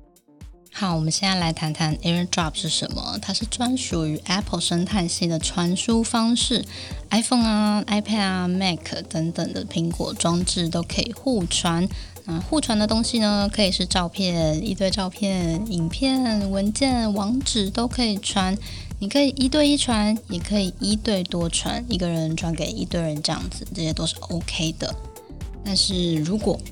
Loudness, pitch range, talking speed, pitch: -23 LUFS, 170-215 Hz, 280 characters per minute, 190 Hz